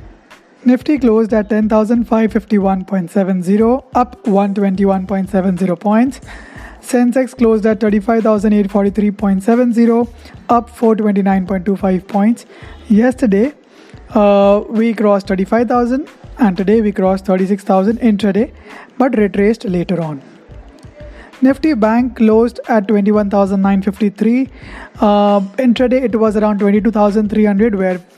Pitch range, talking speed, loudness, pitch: 200-235 Hz, 85 wpm, -14 LUFS, 215 Hz